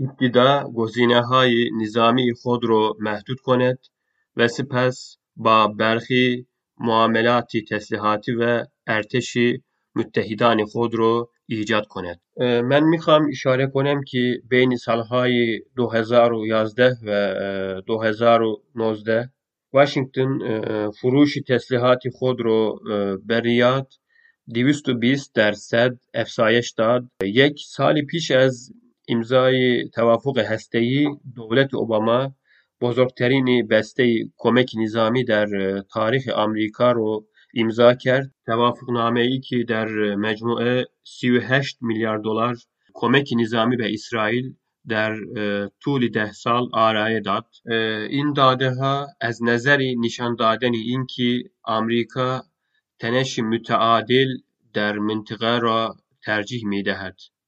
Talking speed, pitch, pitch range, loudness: 105 wpm, 120 Hz, 110-130 Hz, -20 LUFS